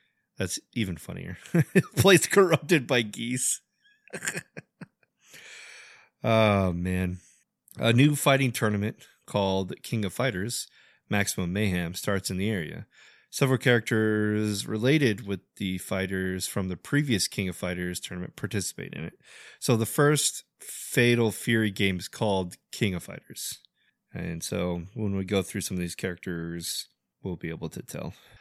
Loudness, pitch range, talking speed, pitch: -27 LUFS, 95-120 Hz, 135 wpm, 105 Hz